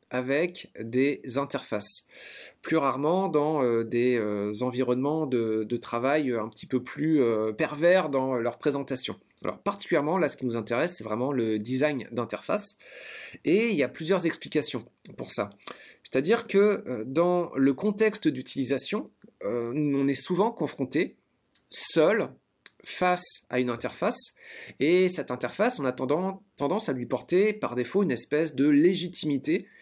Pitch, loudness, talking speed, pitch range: 140 Hz, -27 LUFS, 150 wpm, 125-170 Hz